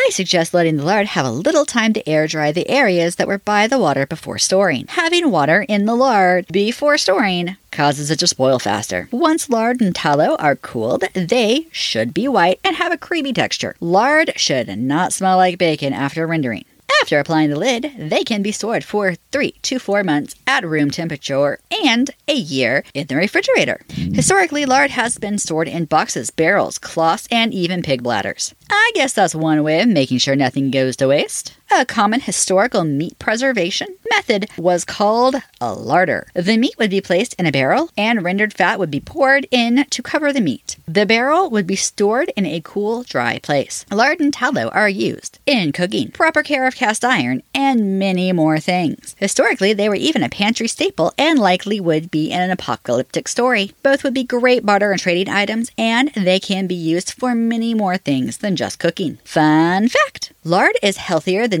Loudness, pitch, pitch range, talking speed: -17 LUFS, 205 Hz, 170-255 Hz, 195 wpm